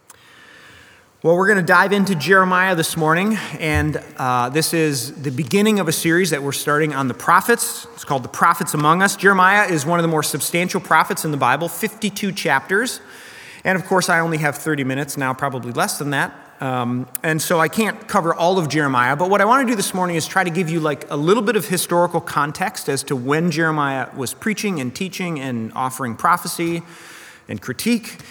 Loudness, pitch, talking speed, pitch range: -18 LUFS, 165 Hz, 210 wpm, 145-190 Hz